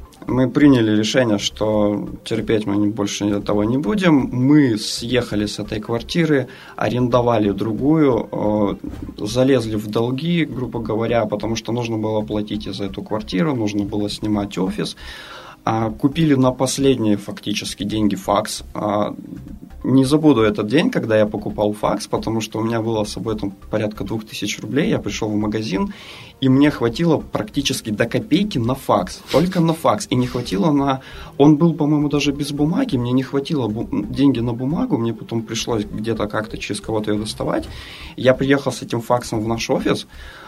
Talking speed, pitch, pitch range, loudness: 160 wpm, 115 Hz, 105-135 Hz, -19 LUFS